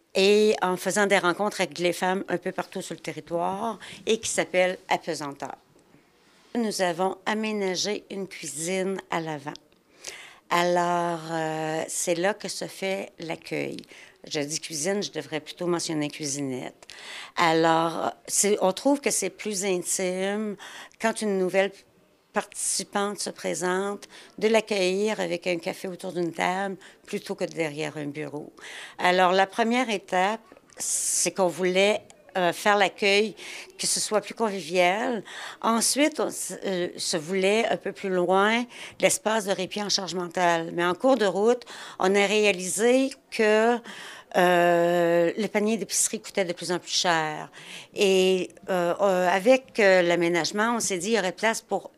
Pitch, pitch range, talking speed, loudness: 185 Hz, 175-205 Hz, 150 wpm, -25 LUFS